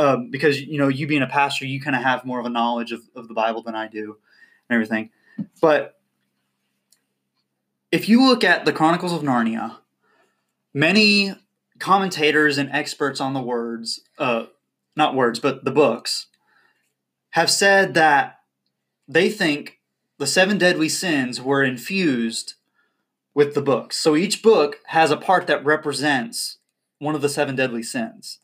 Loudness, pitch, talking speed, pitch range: -20 LUFS, 140 Hz, 160 wpm, 115-160 Hz